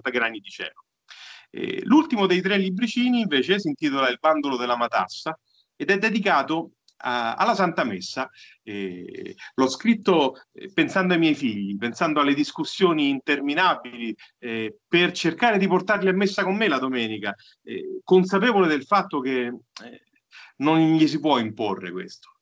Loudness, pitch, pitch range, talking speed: -22 LUFS, 165 Hz, 130-200 Hz, 150 wpm